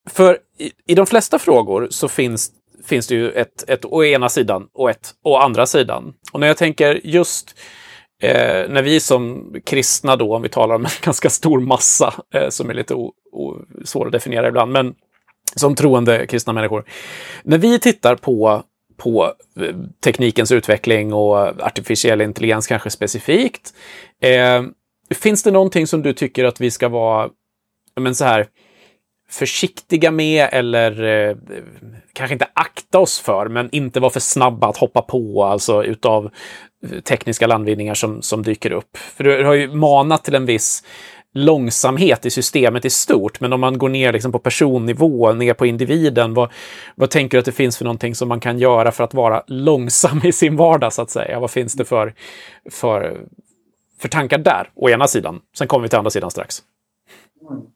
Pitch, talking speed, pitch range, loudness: 125 Hz, 175 wpm, 115-145 Hz, -16 LUFS